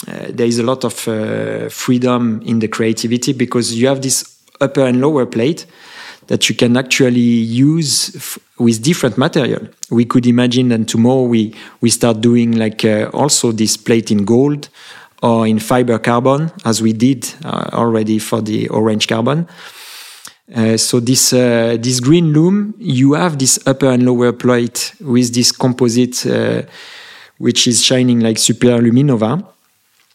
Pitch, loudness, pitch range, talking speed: 120 Hz, -13 LUFS, 115-130 Hz, 160 wpm